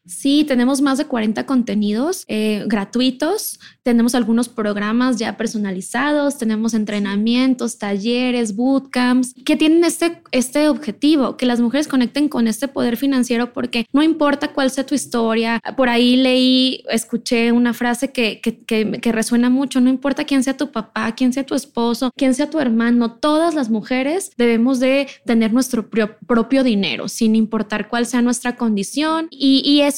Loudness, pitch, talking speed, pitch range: -18 LUFS, 245 Hz, 160 wpm, 230-275 Hz